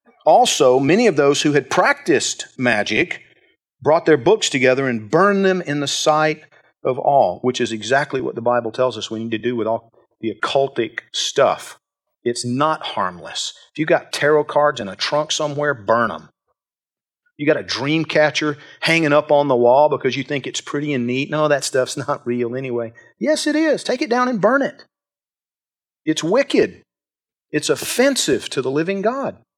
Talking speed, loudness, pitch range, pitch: 185 wpm, -18 LUFS, 125-155 Hz, 145 Hz